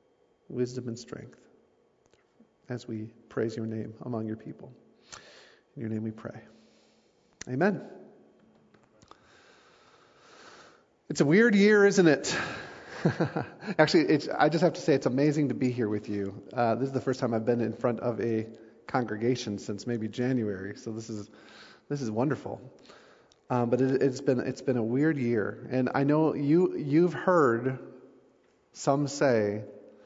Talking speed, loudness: 155 wpm, -28 LUFS